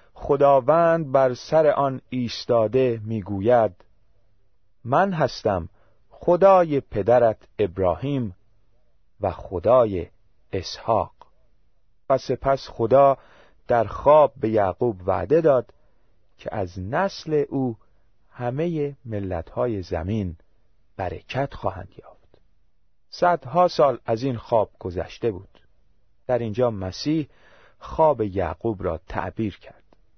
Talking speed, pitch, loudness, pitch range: 95 wpm, 115 Hz, -22 LUFS, 95-135 Hz